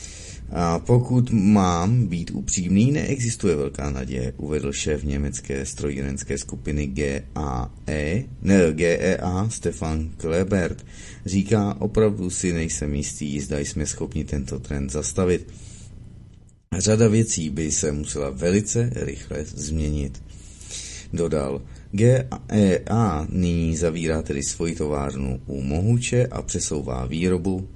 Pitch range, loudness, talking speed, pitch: 75-100 Hz, -23 LUFS, 105 wpm, 85 Hz